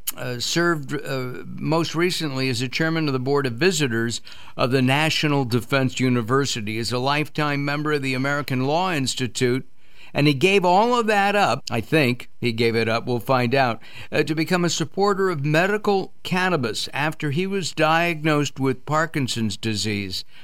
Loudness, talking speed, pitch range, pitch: -22 LUFS, 170 wpm, 125-160 Hz, 140 Hz